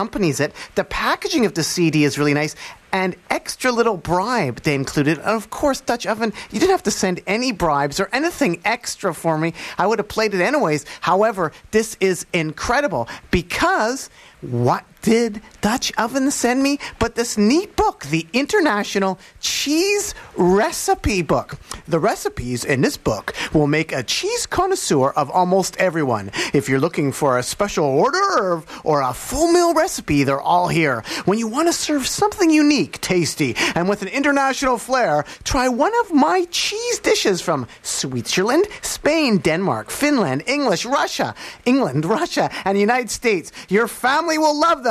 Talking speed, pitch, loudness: 165 wpm, 215 Hz, -19 LUFS